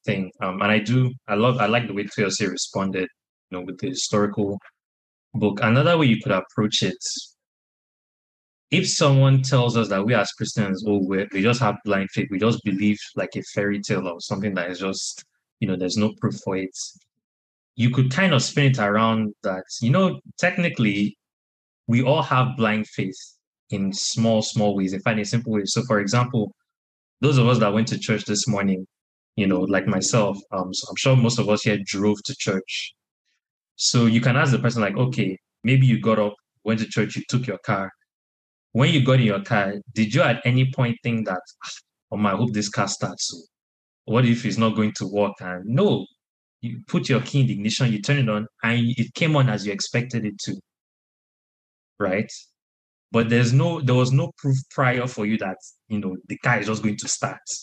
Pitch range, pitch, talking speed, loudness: 100-125 Hz, 110 Hz, 205 wpm, -22 LUFS